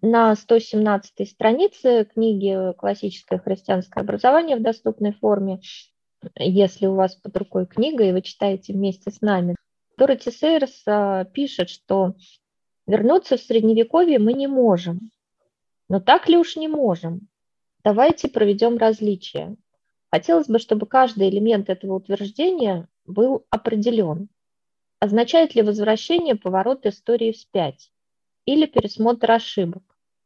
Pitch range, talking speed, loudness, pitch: 195-240 Hz, 115 wpm, -20 LUFS, 215 Hz